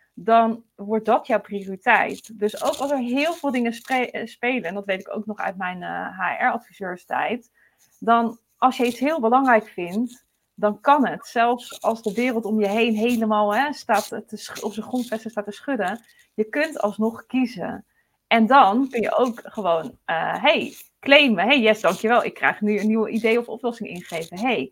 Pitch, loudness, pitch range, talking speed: 225 Hz, -22 LUFS, 210-250 Hz, 190 wpm